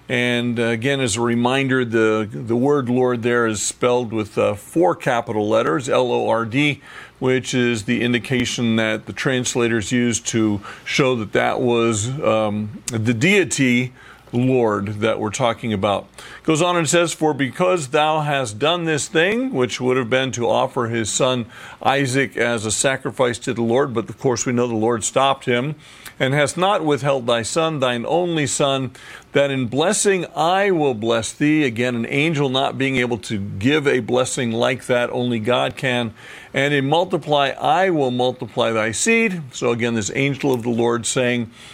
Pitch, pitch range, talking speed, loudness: 125 Hz, 115-140 Hz, 180 wpm, -19 LUFS